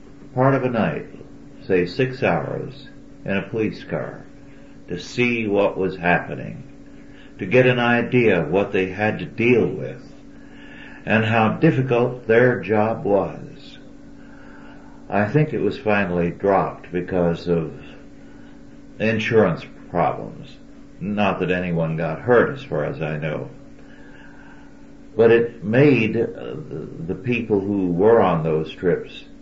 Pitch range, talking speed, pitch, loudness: 90-125 Hz, 130 wpm, 110 Hz, -20 LUFS